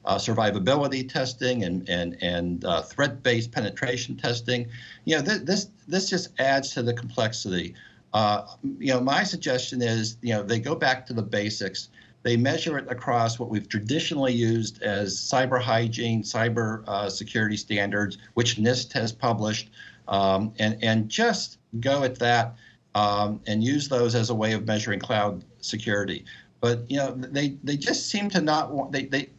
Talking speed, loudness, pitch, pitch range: 170 wpm, -26 LUFS, 120 Hz, 105-135 Hz